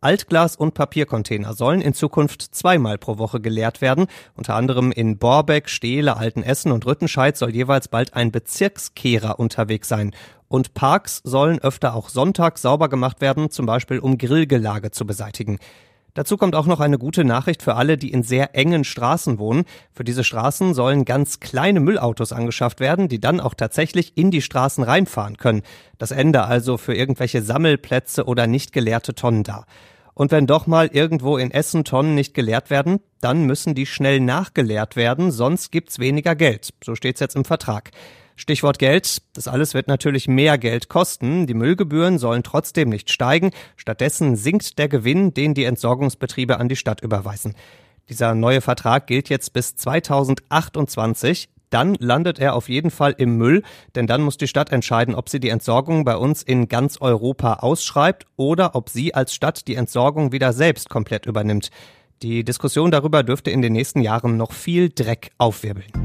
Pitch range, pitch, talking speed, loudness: 120-150 Hz, 130 Hz, 175 wpm, -19 LUFS